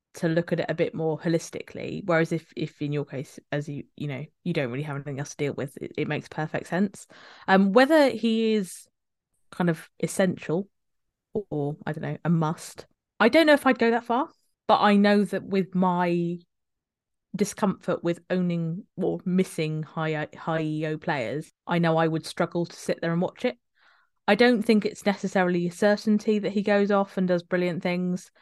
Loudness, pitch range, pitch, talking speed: -25 LUFS, 160-205 Hz, 175 Hz, 200 wpm